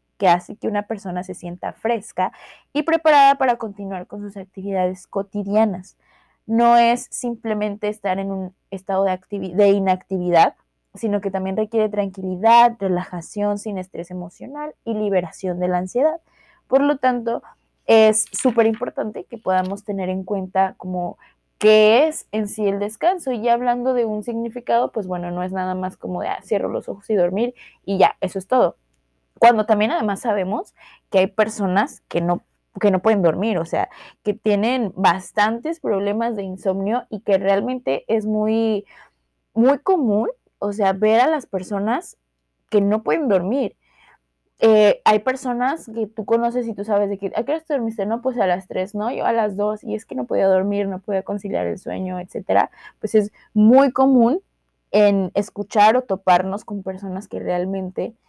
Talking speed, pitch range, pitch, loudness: 175 wpm, 190-230 Hz, 205 Hz, -20 LUFS